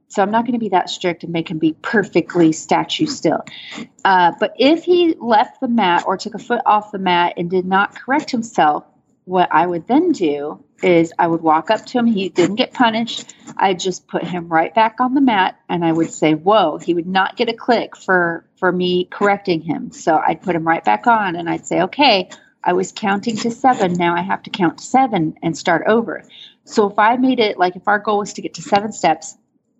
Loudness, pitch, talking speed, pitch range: -17 LUFS, 195 Hz, 235 wpm, 175-230 Hz